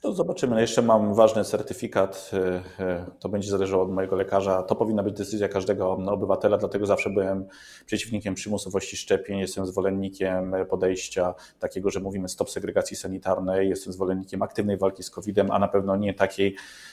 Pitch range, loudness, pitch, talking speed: 95-100 Hz, -26 LUFS, 95 Hz, 155 wpm